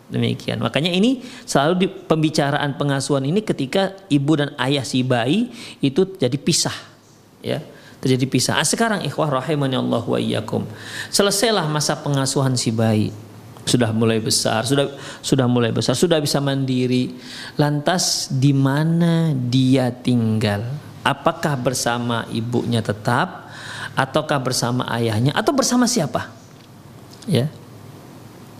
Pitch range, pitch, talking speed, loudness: 125-155 Hz, 135 Hz, 120 wpm, -20 LUFS